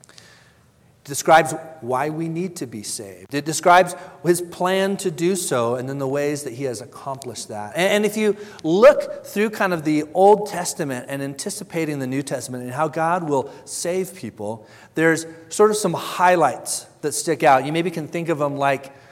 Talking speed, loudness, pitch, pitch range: 185 wpm, -21 LUFS, 160 Hz, 140-180 Hz